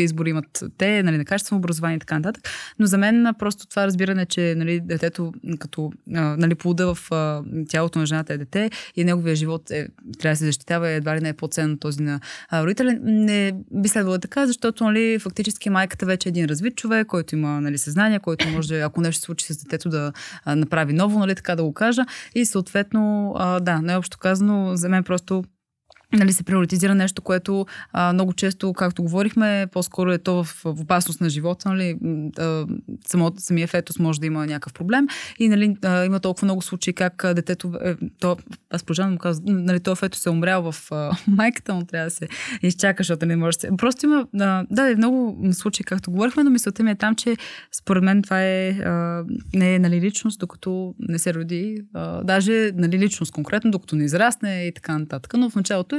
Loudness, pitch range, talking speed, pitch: -22 LUFS, 165-200 Hz, 205 wpm, 185 Hz